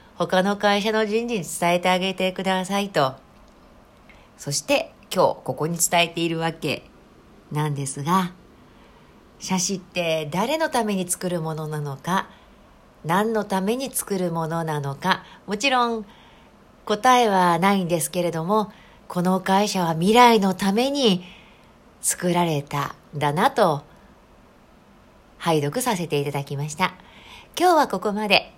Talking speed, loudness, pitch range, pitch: 255 characters per minute, -22 LUFS, 165-210 Hz, 185 Hz